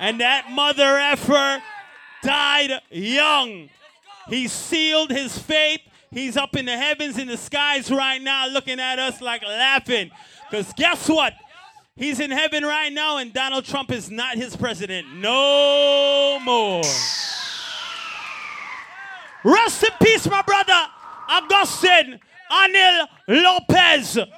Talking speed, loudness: 125 wpm, -18 LUFS